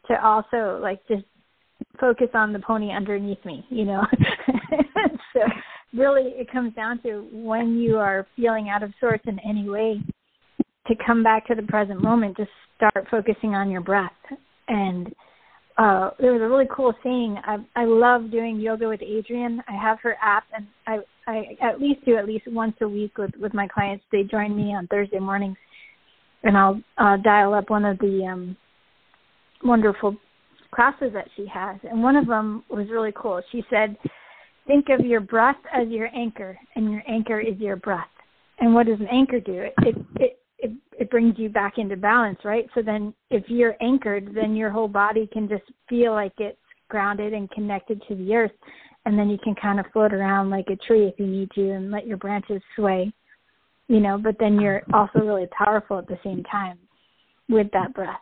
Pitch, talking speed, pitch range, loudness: 215 Hz, 195 wpm, 200-230 Hz, -23 LUFS